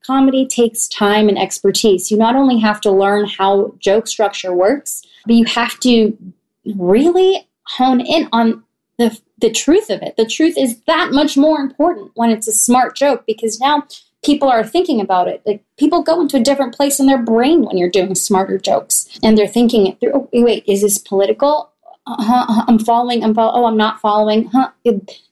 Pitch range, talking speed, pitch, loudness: 210-275 Hz, 200 wpm, 230 Hz, -14 LUFS